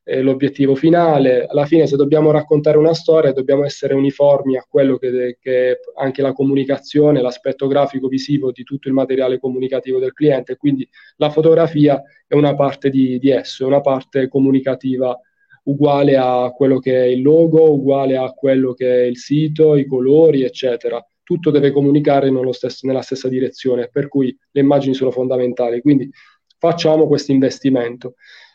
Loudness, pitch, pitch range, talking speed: -15 LUFS, 135 Hz, 130-145 Hz, 165 wpm